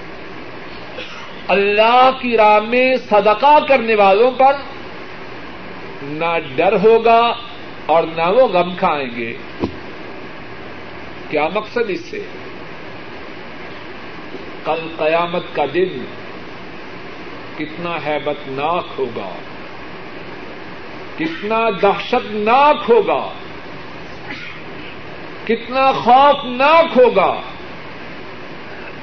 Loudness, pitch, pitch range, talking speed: -15 LUFS, 225 Hz, 170-265 Hz, 70 wpm